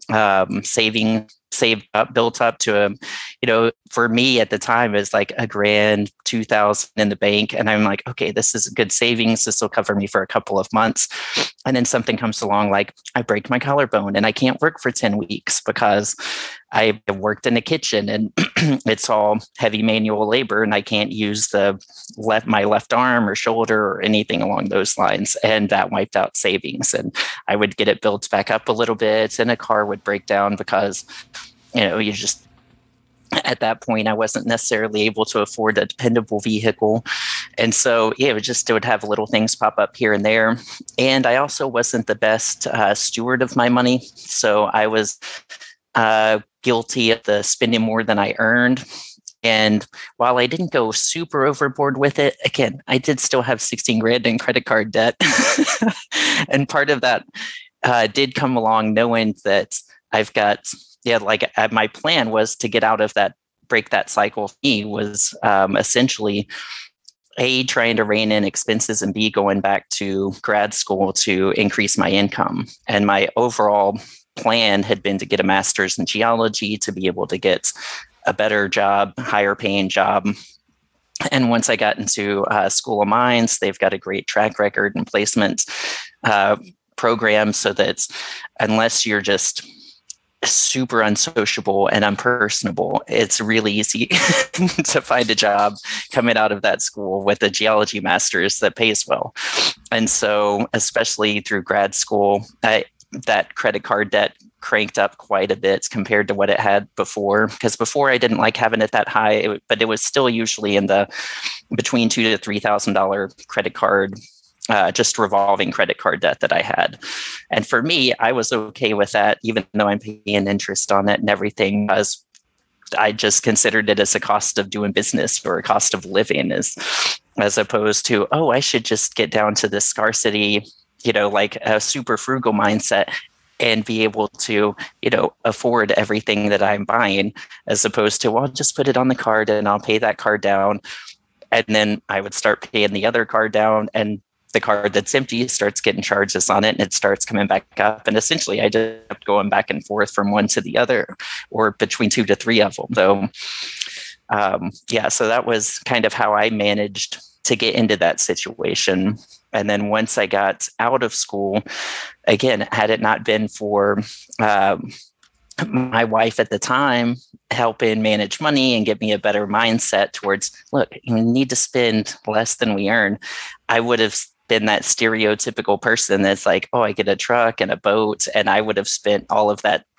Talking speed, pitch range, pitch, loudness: 190 wpm, 105-115 Hz, 110 Hz, -18 LUFS